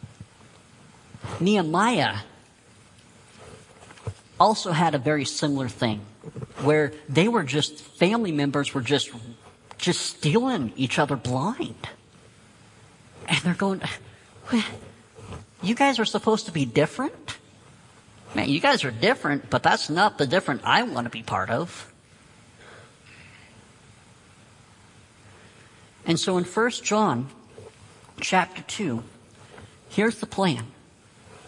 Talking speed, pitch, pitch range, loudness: 105 wpm, 140 Hz, 115-175 Hz, -24 LUFS